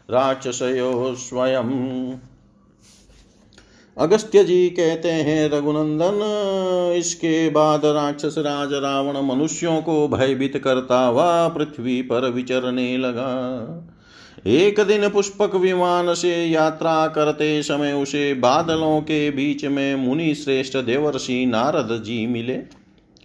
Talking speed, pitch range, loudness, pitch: 105 wpm, 130-160 Hz, -20 LUFS, 145 Hz